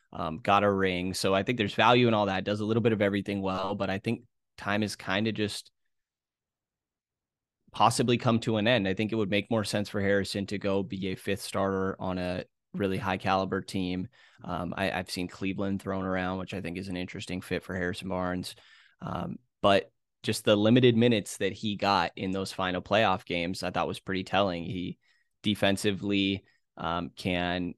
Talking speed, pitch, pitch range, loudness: 205 wpm, 95 Hz, 95-105 Hz, -29 LUFS